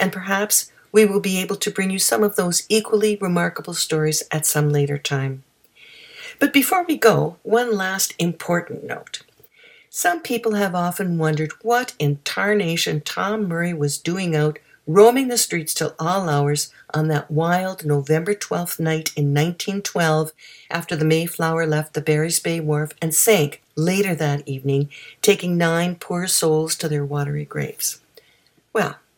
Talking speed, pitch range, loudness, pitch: 155 wpm, 155-200 Hz, -20 LUFS, 170 Hz